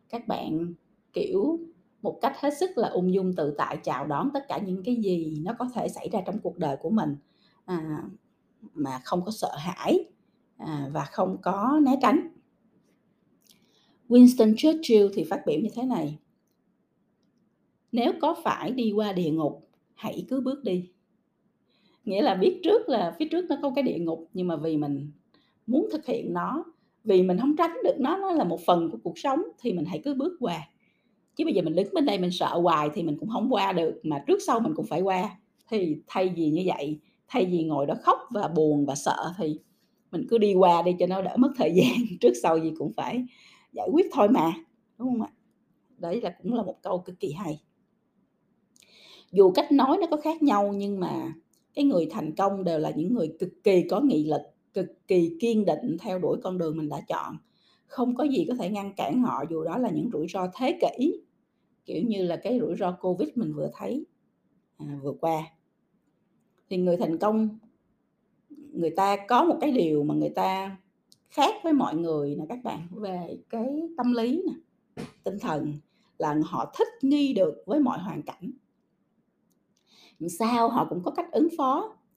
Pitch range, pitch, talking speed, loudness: 170-270 Hz, 210 Hz, 200 wpm, -26 LUFS